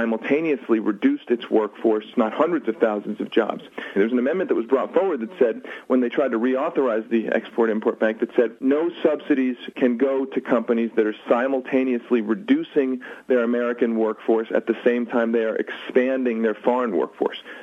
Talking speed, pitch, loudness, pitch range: 175 wpm, 120 Hz, -22 LUFS, 115-130 Hz